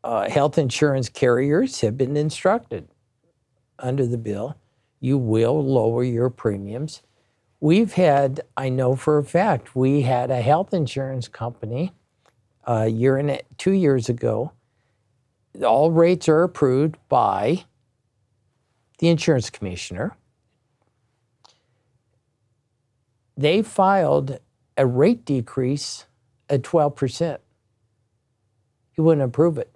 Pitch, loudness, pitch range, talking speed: 130 Hz, -21 LUFS, 120-145 Hz, 110 wpm